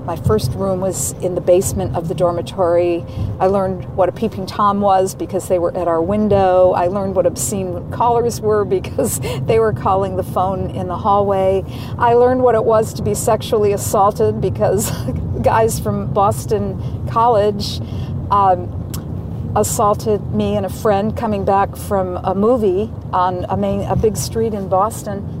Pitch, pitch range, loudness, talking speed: 185 Hz, 150-205 Hz, -17 LUFS, 170 wpm